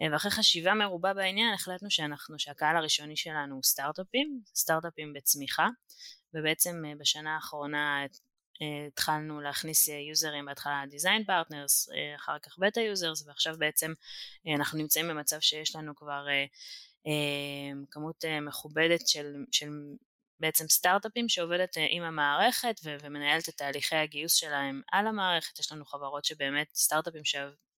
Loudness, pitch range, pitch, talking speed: -29 LUFS, 145-170 Hz, 155 Hz, 125 wpm